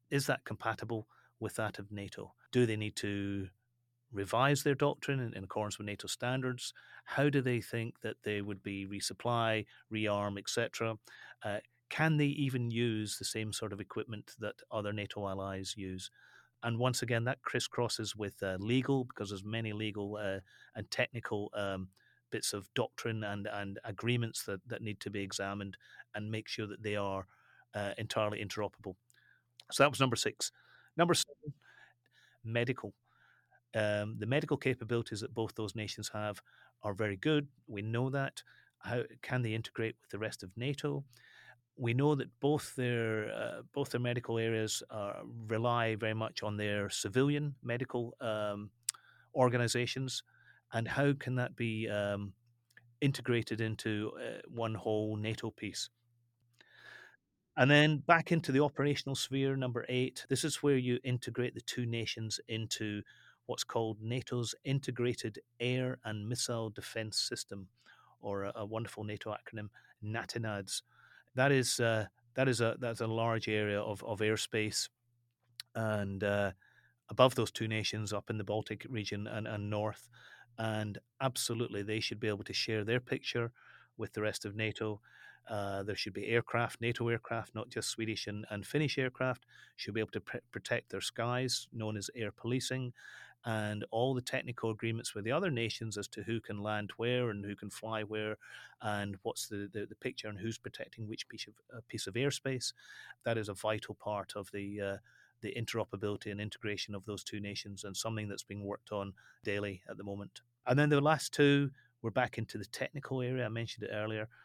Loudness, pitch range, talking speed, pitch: -36 LUFS, 105-125 Hz, 170 wpm, 110 Hz